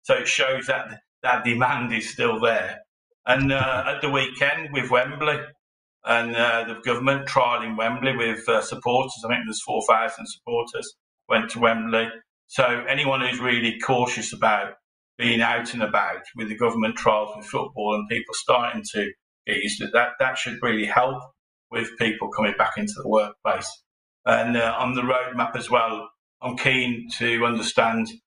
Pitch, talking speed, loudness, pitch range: 120 Hz, 170 wpm, -23 LUFS, 115-135 Hz